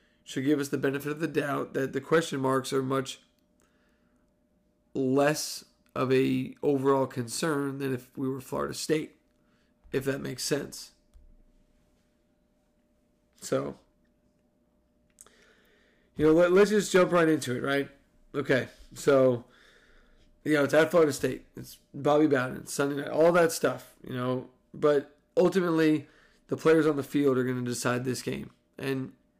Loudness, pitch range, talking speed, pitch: -27 LUFS, 125-150 Hz, 145 wpm, 140 Hz